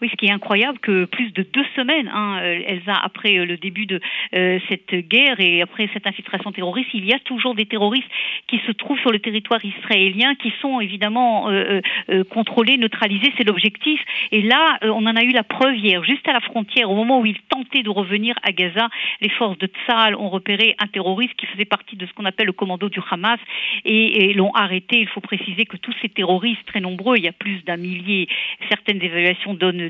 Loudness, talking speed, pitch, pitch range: -18 LUFS, 220 wpm, 210 Hz, 195-235 Hz